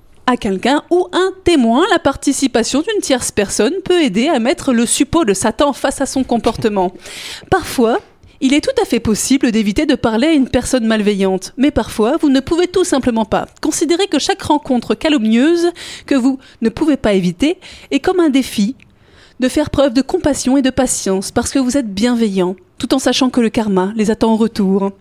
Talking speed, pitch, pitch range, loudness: 195 wpm, 265 Hz, 225-300 Hz, -15 LUFS